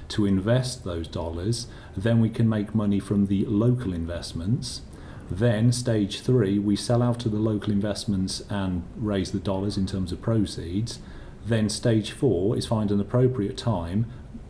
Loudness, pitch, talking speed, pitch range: -25 LUFS, 105 Hz, 160 wpm, 95-115 Hz